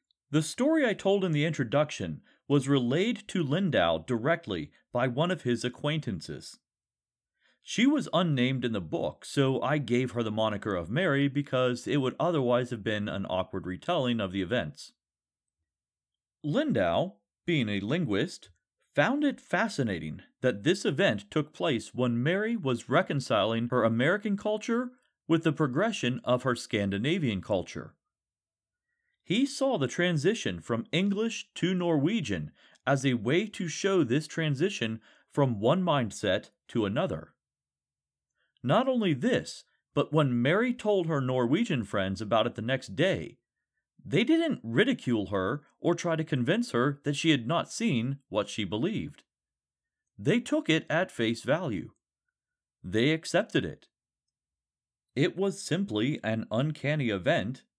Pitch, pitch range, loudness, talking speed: 140 Hz, 120-180 Hz, -29 LUFS, 140 wpm